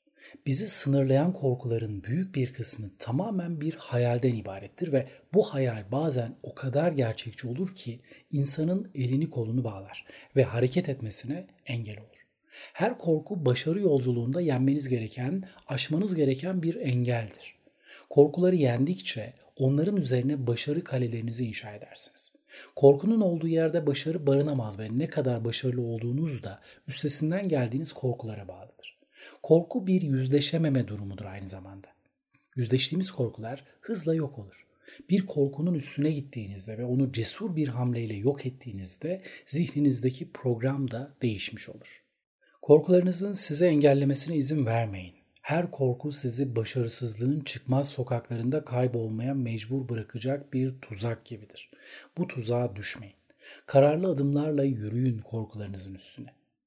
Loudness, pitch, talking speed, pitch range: -27 LUFS, 135 Hz, 120 wpm, 115-150 Hz